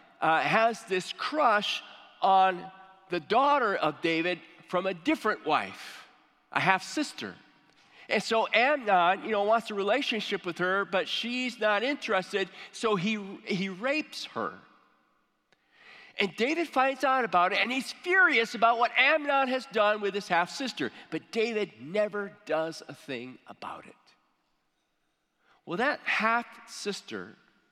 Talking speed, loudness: 140 wpm, -28 LUFS